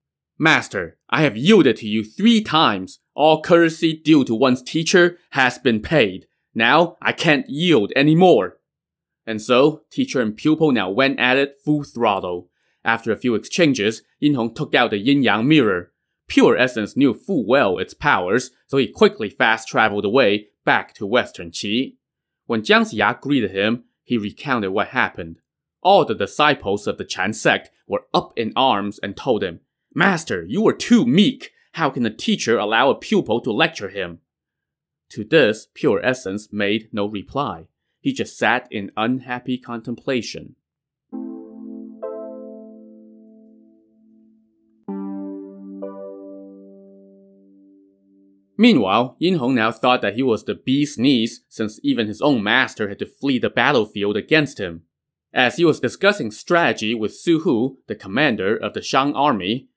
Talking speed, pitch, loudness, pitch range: 150 wpm, 110 Hz, -19 LUFS, 100-150 Hz